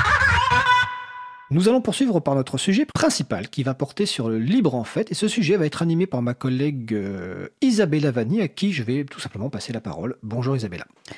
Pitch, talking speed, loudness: 150 Hz, 200 wpm, -22 LUFS